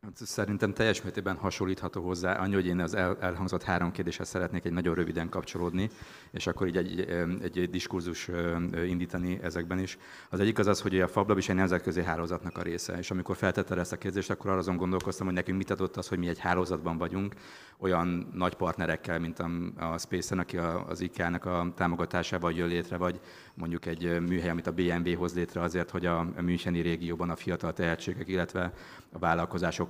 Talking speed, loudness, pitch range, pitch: 190 wpm, -32 LUFS, 85-95 Hz, 90 Hz